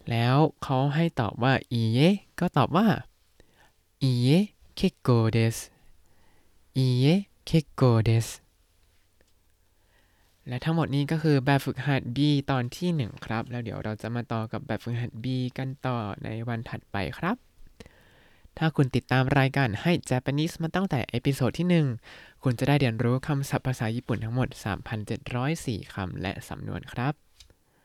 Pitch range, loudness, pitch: 115-140 Hz, -27 LUFS, 125 Hz